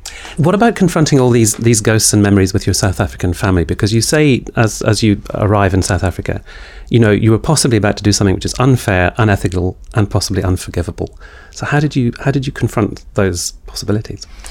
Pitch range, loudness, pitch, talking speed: 95-120 Hz, -14 LUFS, 105 Hz, 205 wpm